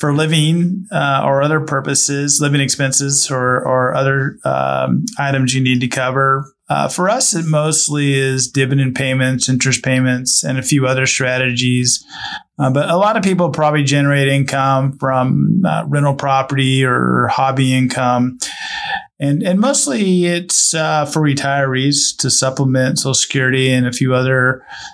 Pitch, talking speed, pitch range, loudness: 135 Hz, 150 wpm, 130-150 Hz, -14 LUFS